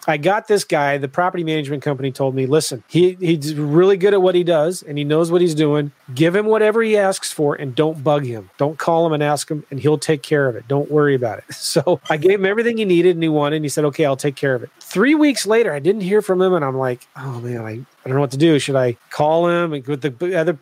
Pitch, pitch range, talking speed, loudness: 155 Hz, 140-180 Hz, 290 wpm, -17 LUFS